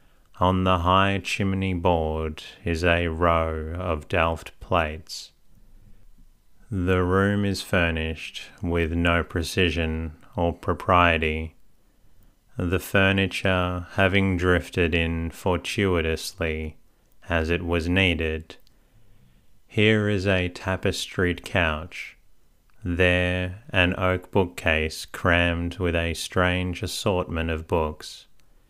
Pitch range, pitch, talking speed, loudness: 80-95 Hz, 90 Hz, 95 wpm, -24 LUFS